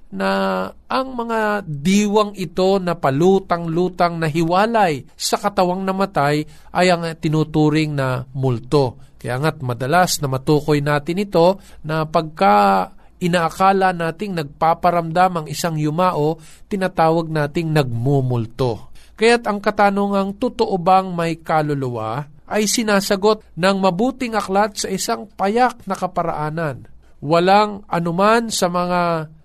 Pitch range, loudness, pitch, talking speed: 150-200 Hz, -18 LUFS, 175 Hz, 115 wpm